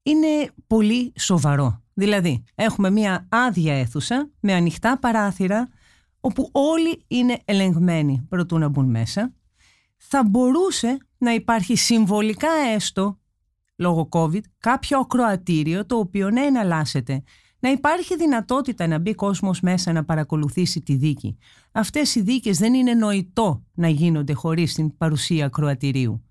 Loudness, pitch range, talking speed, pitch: -21 LUFS, 160-245 Hz, 130 wpm, 200 Hz